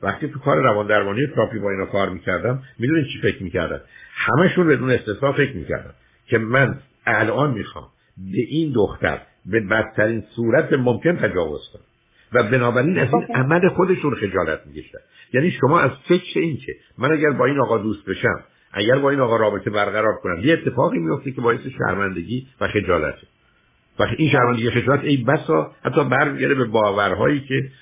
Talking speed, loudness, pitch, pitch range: 170 wpm, -20 LUFS, 130 Hz, 110-150 Hz